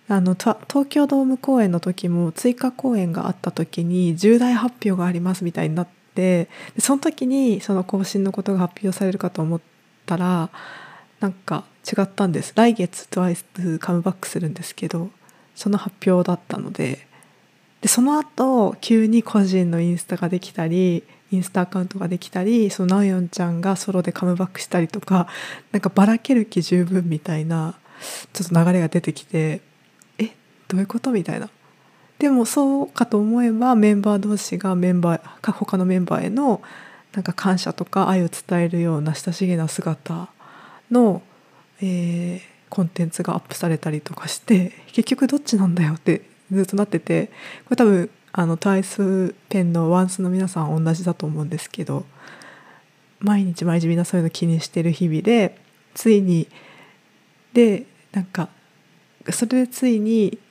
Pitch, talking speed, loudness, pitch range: 185 Hz, 335 characters per minute, -21 LUFS, 175-210 Hz